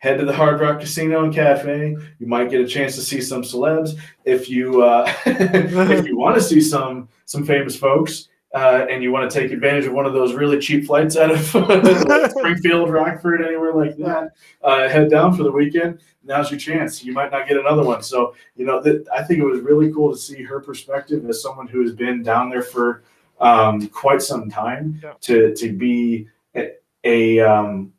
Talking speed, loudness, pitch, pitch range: 210 wpm, -17 LUFS, 140 Hz, 125-155 Hz